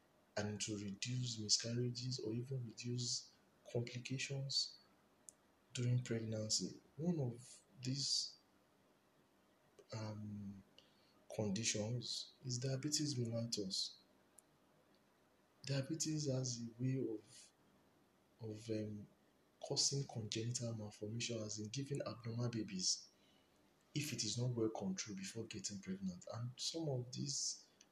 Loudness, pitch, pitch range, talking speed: -43 LUFS, 120 Hz, 110-130 Hz, 100 wpm